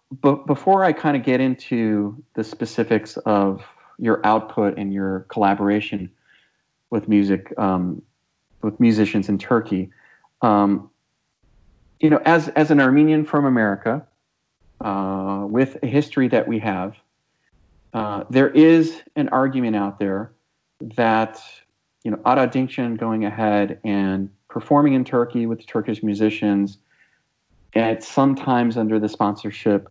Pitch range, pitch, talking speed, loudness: 100-130 Hz, 110 Hz, 130 wpm, -20 LUFS